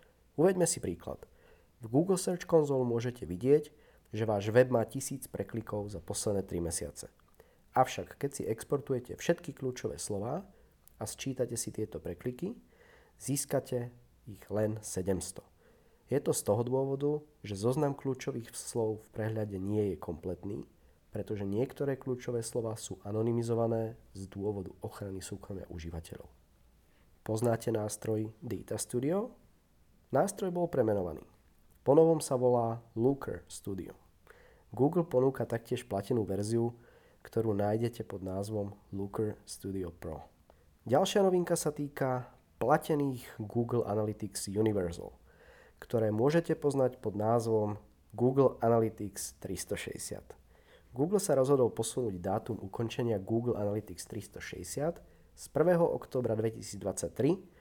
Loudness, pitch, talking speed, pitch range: -33 LUFS, 115 Hz, 120 wpm, 100-130 Hz